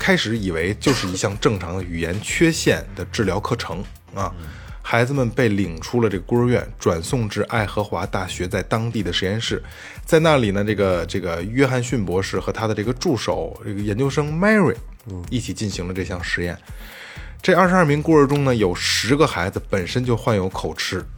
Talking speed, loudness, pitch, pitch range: 305 characters per minute, -20 LUFS, 105 Hz, 95-125 Hz